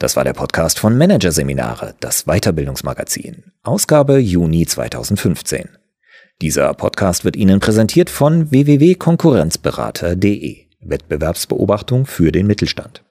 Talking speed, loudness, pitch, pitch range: 100 wpm, -15 LUFS, 105 Hz, 85-145 Hz